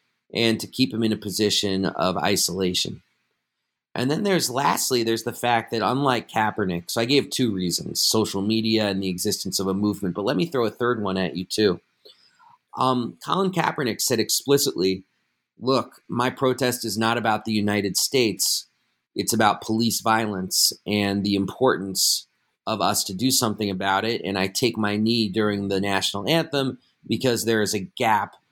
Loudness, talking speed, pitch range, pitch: -23 LUFS, 175 wpm, 95-120 Hz, 110 Hz